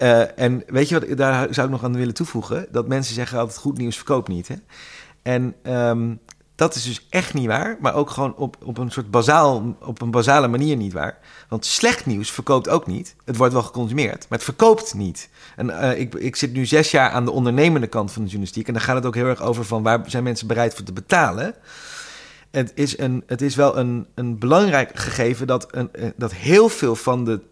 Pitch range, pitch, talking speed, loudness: 115-140 Hz, 125 Hz, 230 wpm, -20 LUFS